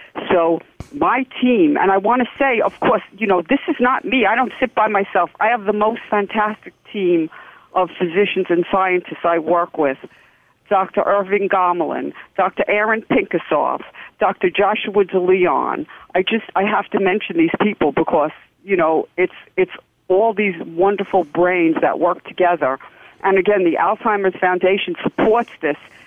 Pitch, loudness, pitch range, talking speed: 195 Hz, -18 LUFS, 180-220 Hz, 160 wpm